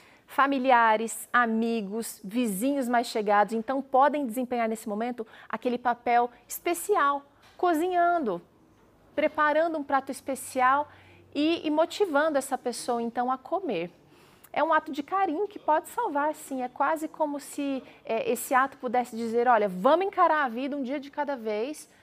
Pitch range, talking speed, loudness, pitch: 240-305 Hz, 145 wpm, -27 LUFS, 270 Hz